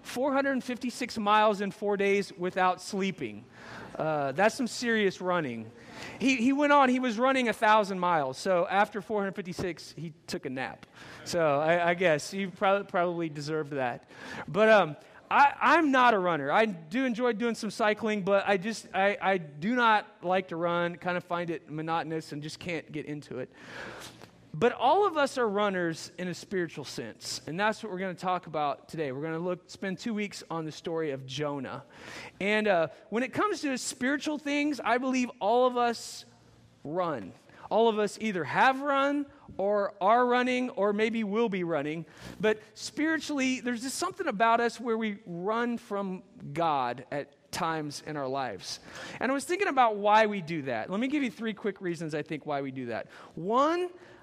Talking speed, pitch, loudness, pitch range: 200 wpm, 205 Hz, -29 LUFS, 170-240 Hz